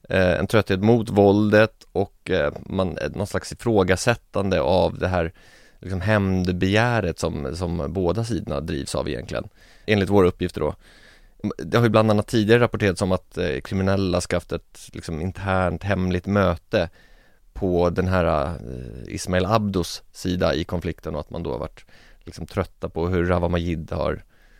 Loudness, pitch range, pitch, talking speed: -23 LUFS, 85-100 Hz, 95 Hz, 150 wpm